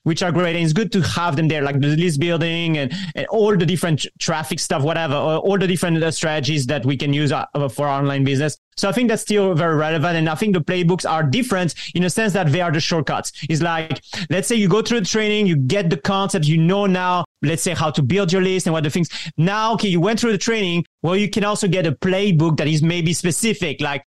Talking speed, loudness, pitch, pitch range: 255 wpm, -19 LUFS, 170 Hz, 155-195 Hz